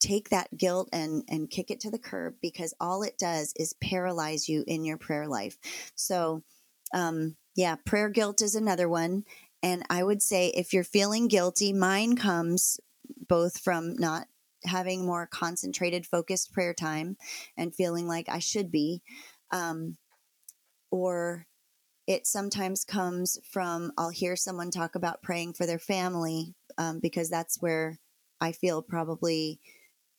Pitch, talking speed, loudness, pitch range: 175 Hz, 150 wpm, -30 LUFS, 165-190 Hz